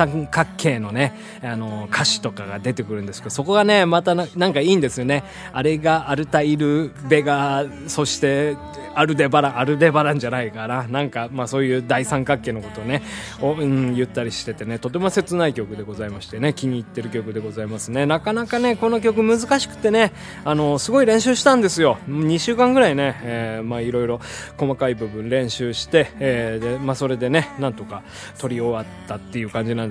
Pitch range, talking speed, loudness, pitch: 115-155 Hz, 400 characters per minute, -20 LUFS, 135 Hz